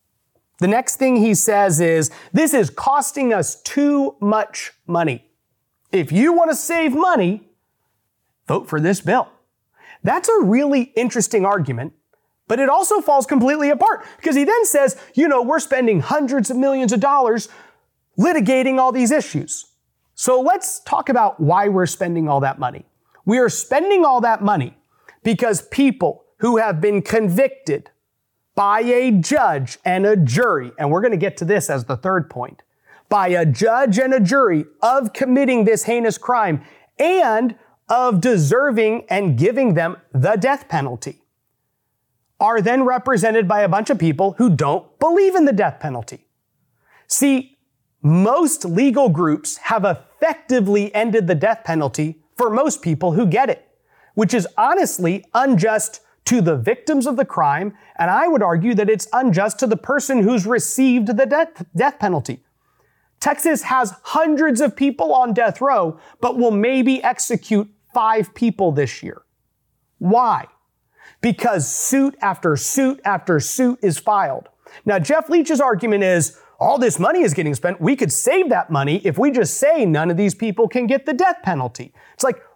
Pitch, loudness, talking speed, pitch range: 225 Hz, -17 LUFS, 160 wpm, 175-270 Hz